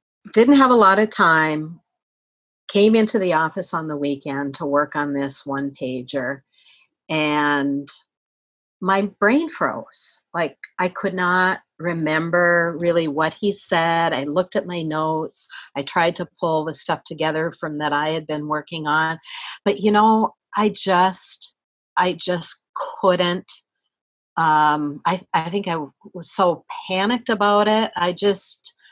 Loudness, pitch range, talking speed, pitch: -20 LUFS, 150-190 Hz, 145 wpm, 165 Hz